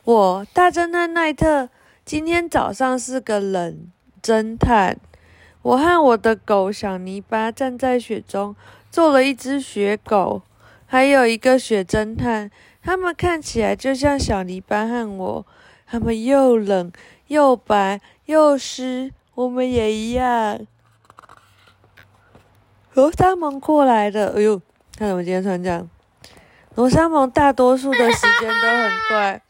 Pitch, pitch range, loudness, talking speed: 230 Hz, 200-265 Hz, -18 LUFS, 185 characters per minute